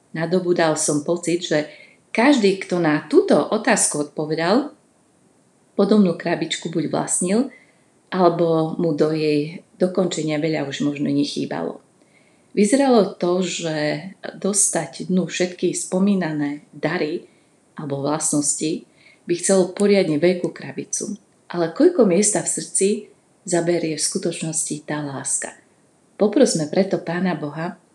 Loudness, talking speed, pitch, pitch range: -20 LUFS, 115 wpm, 175 Hz, 155-195 Hz